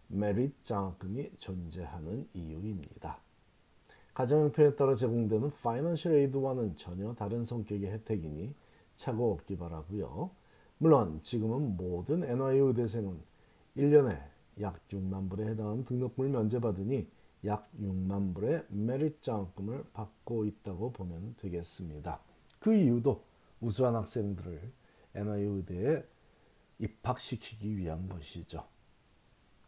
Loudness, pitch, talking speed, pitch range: -34 LUFS, 105 Hz, 275 characters per minute, 95-125 Hz